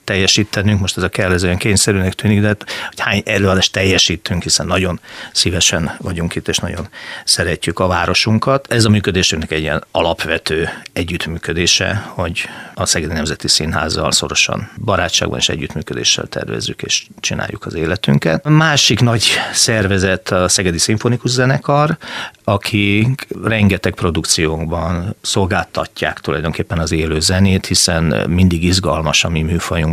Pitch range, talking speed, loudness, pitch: 80-105 Hz, 130 wpm, -15 LUFS, 90 Hz